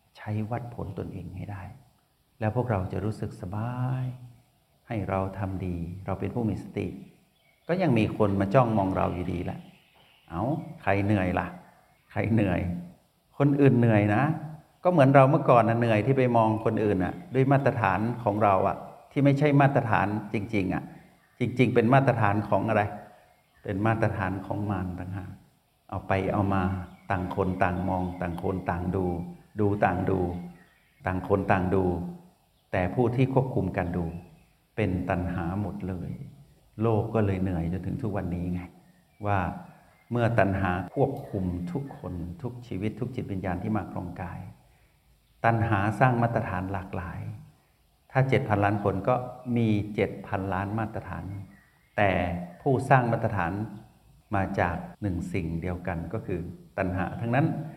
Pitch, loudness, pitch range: 100 Hz, -27 LUFS, 95-120 Hz